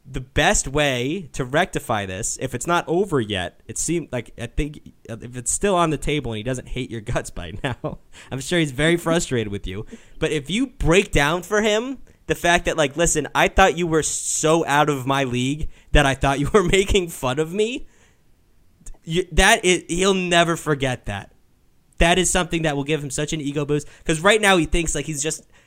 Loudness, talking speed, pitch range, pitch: -21 LUFS, 215 wpm, 130-170 Hz, 150 Hz